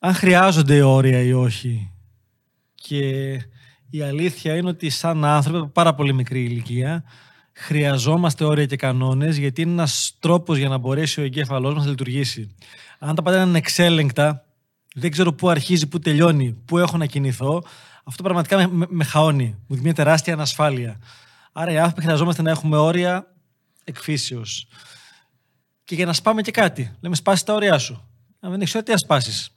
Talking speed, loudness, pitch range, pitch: 165 wpm, -19 LUFS, 130-170 Hz, 150 Hz